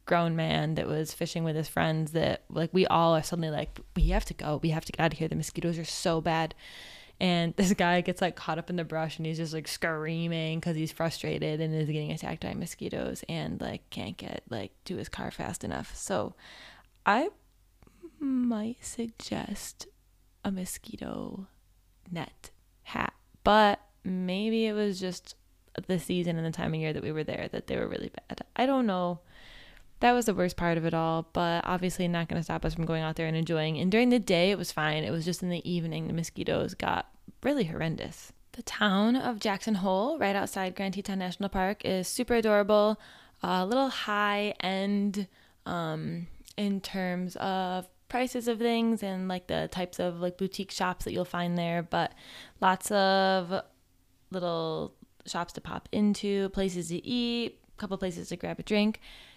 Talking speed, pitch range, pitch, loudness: 195 wpm, 165-205 Hz, 180 Hz, -30 LUFS